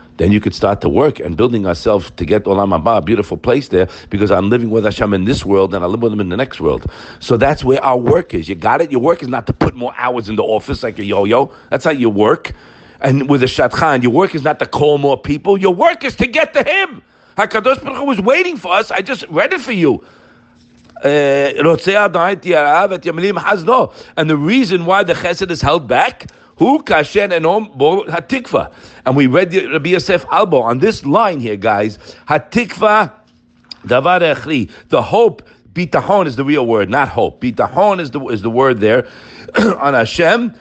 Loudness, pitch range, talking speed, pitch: -13 LUFS, 130-205 Hz, 200 wpm, 165 Hz